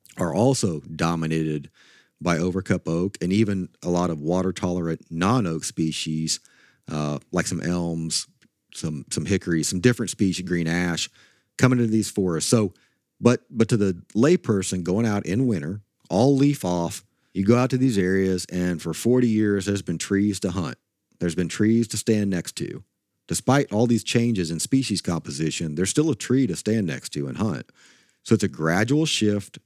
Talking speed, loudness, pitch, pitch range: 180 wpm, -23 LUFS, 95 Hz, 85-115 Hz